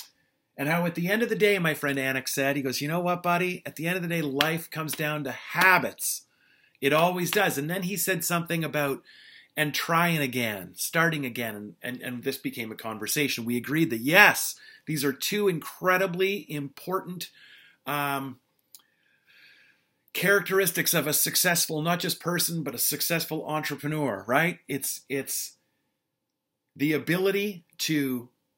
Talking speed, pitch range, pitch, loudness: 160 wpm, 140-180 Hz, 155 Hz, -26 LUFS